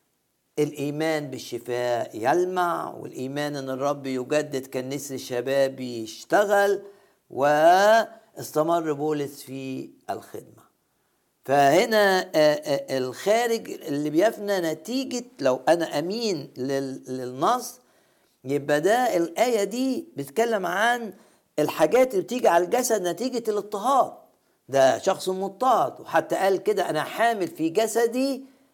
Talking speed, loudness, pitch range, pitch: 95 wpm, -24 LUFS, 140-220 Hz, 165 Hz